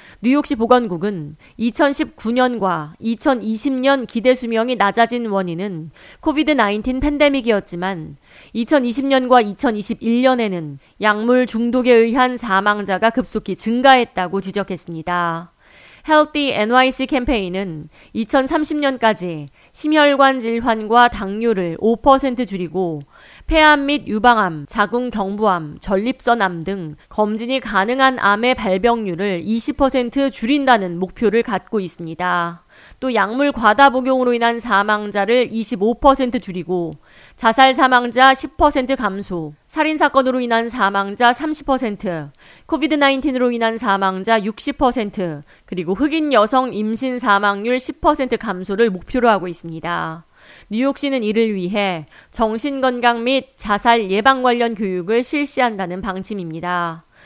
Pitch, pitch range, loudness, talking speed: 230 Hz, 195-260 Hz, -17 LUFS, 245 characters per minute